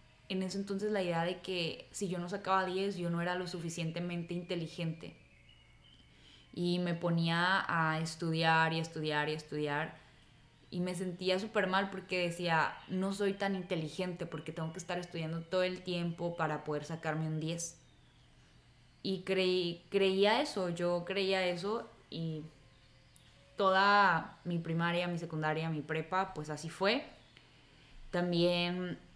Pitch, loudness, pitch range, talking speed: 175 Hz, -34 LUFS, 160-185 Hz, 150 wpm